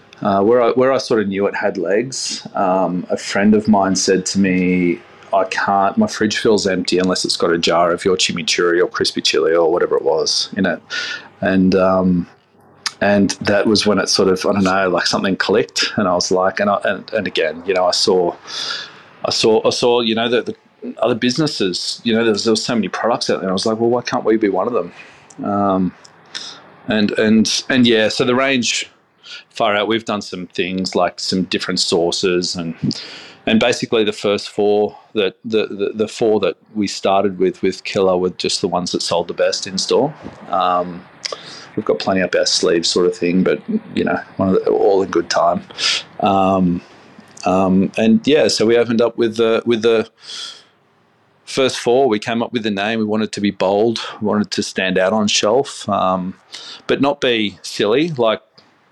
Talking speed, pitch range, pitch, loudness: 210 wpm, 95-120 Hz, 105 Hz, -17 LUFS